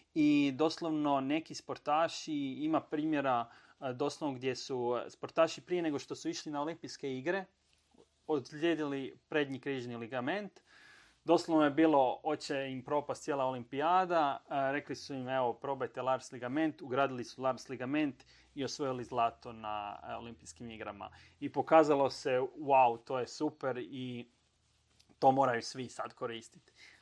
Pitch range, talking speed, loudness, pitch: 130-160 Hz, 135 wpm, -34 LUFS, 140 Hz